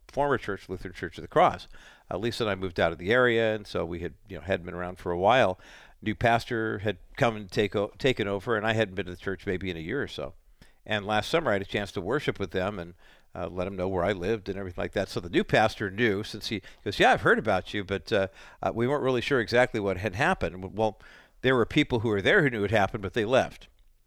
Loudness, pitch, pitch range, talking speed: -27 LUFS, 105 Hz, 95-115 Hz, 280 wpm